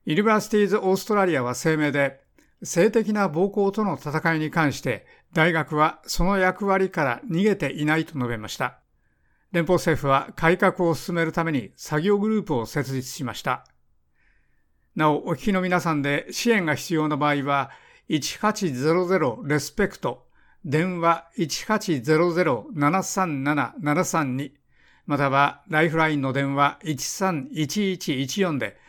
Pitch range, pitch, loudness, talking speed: 145-185 Hz, 160 Hz, -23 LUFS, 255 characters per minute